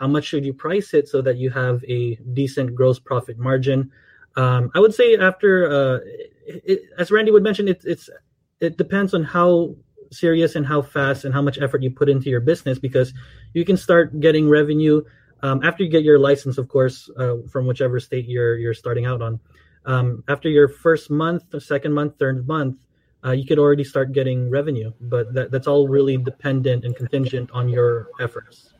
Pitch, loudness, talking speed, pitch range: 135 Hz, -19 LUFS, 200 wpm, 125-155 Hz